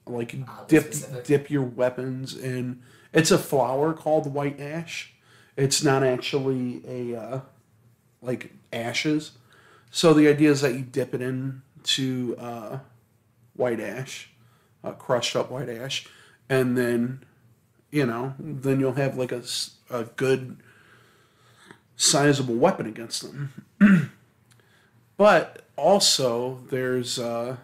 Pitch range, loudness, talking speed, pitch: 120-145 Hz, -24 LUFS, 120 wpm, 130 Hz